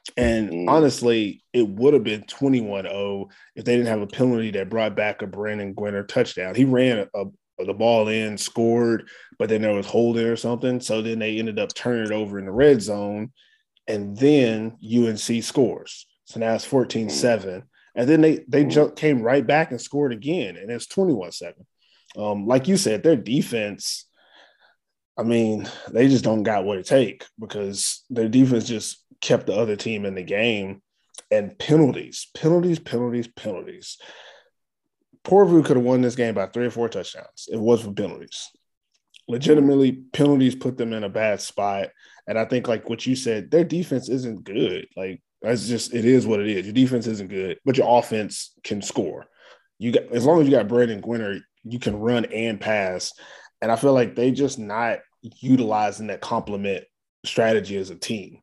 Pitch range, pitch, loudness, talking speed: 105-130 Hz, 115 Hz, -22 LUFS, 185 wpm